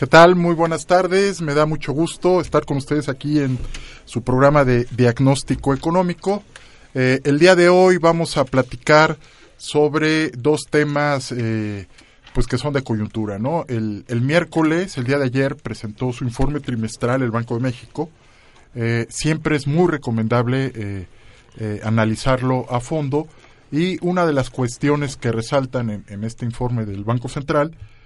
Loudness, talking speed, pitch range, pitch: -19 LUFS, 165 wpm, 120-155 Hz, 135 Hz